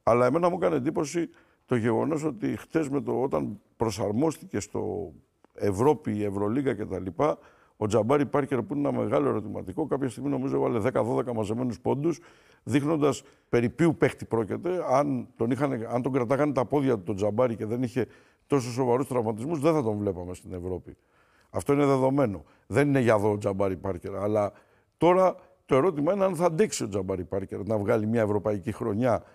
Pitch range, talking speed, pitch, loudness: 105-145 Hz, 170 wpm, 125 Hz, -27 LUFS